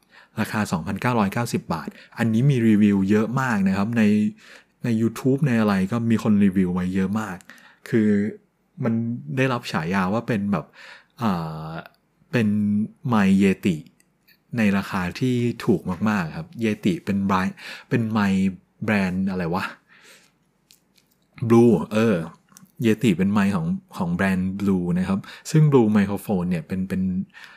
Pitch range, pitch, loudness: 100-155 Hz, 115 Hz, -22 LUFS